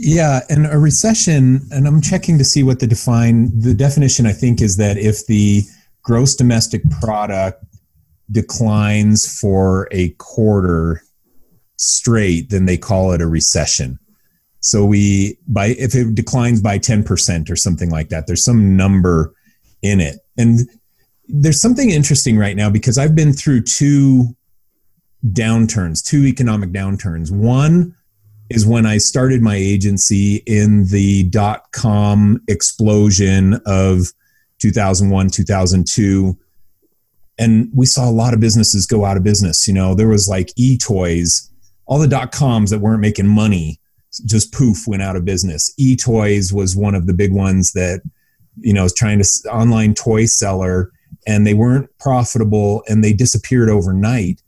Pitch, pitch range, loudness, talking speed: 105 Hz, 95-120 Hz, -14 LUFS, 150 wpm